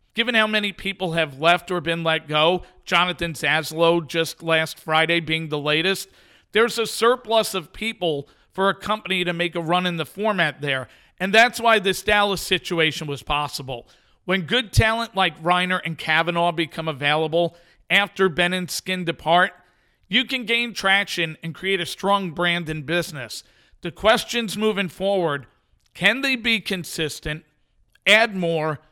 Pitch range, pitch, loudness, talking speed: 160-200 Hz, 175 Hz, -21 LUFS, 160 wpm